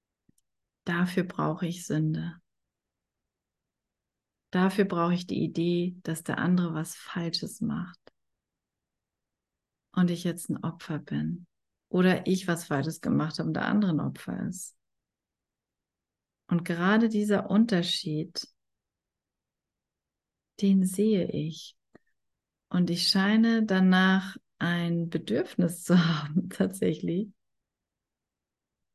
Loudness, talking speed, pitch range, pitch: -28 LUFS, 100 wpm, 160-190 Hz, 175 Hz